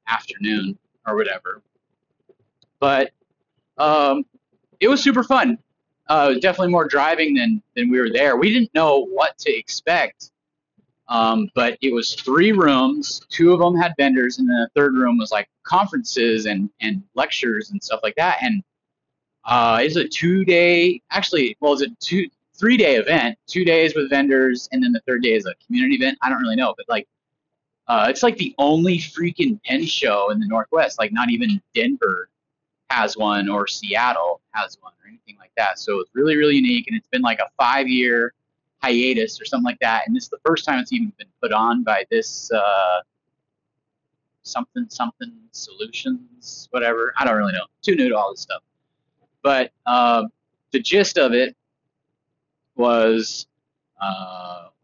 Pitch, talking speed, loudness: 155 Hz, 180 wpm, -19 LUFS